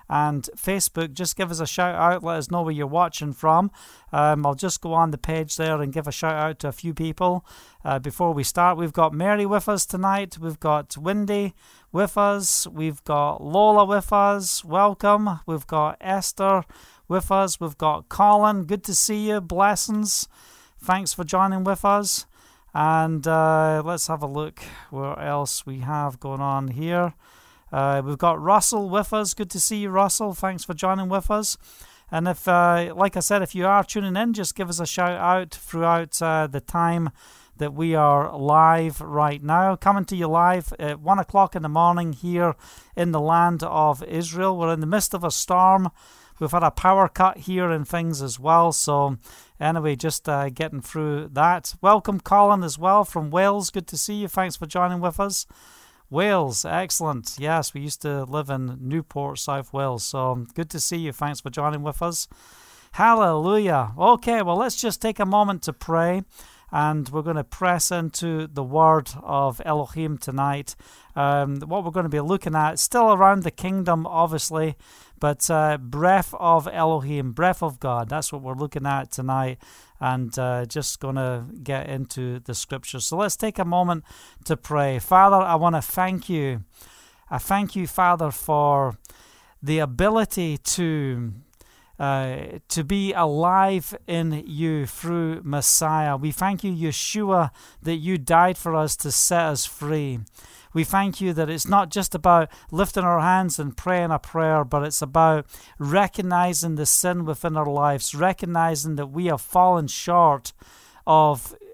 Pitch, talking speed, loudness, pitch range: 165 Hz, 180 wpm, -22 LUFS, 150-185 Hz